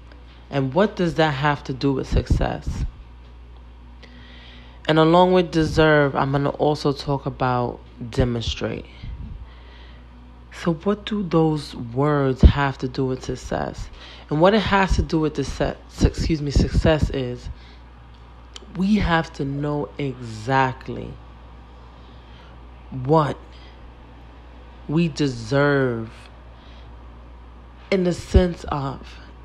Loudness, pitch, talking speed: -21 LUFS, 120 Hz, 110 wpm